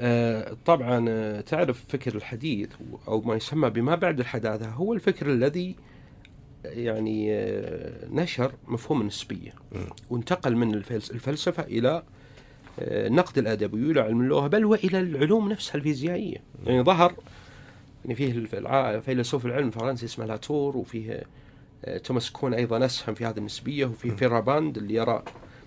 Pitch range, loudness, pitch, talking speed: 115-145 Hz, -27 LUFS, 125 Hz, 120 wpm